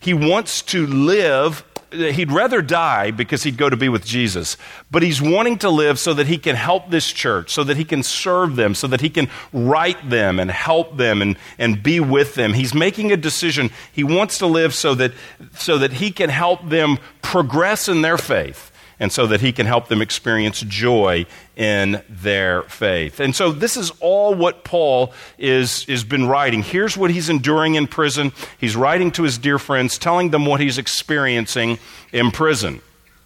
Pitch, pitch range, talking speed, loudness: 140 Hz, 120-165 Hz, 195 wpm, -18 LUFS